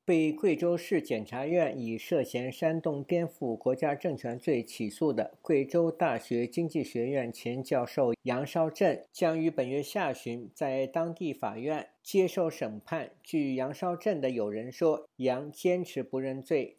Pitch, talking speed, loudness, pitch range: 140 Hz, 230 characters per minute, -31 LUFS, 125-170 Hz